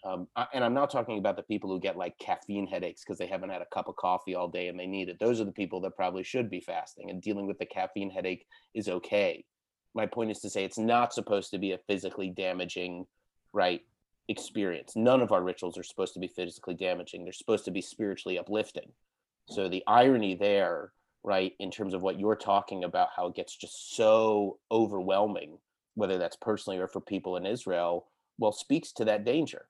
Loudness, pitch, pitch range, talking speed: -31 LUFS, 95 Hz, 90-105 Hz, 215 wpm